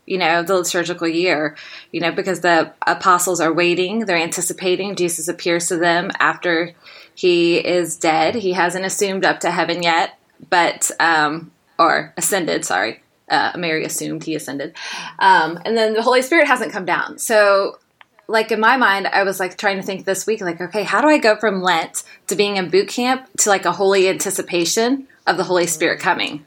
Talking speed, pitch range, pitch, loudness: 190 wpm, 170-205 Hz, 180 Hz, -17 LUFS